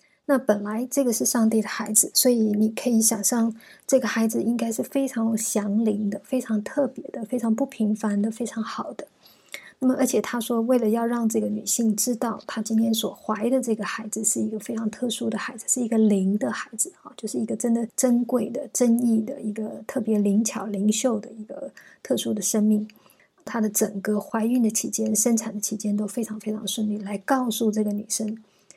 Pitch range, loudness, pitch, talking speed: 215-245 Hz, -24 LUFS, 225 Hz, 300 characters per minute